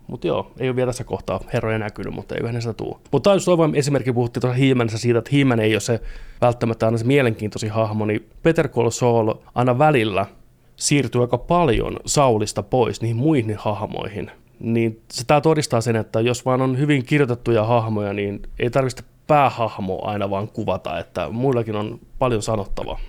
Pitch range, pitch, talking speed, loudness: 110-130 Hz, 120 Hz, 180 wpm, -20 LUFS